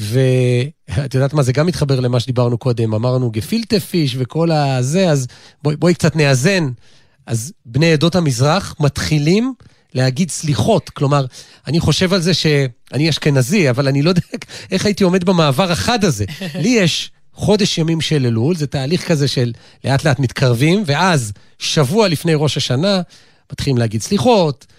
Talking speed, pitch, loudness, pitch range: 155 wpm, 150 Hz, -16 LUFS, 130-175 Hz